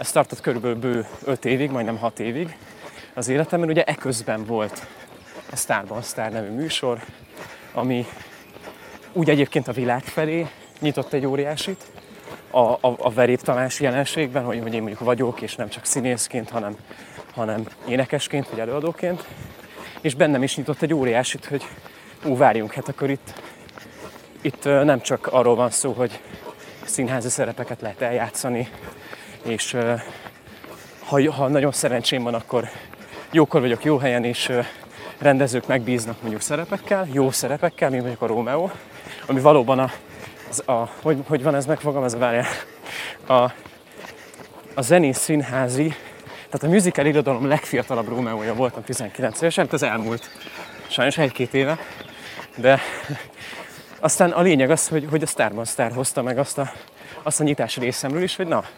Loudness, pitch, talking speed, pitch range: -22 LUFS, 130 Hz, 150 wpm, 120-150 Hz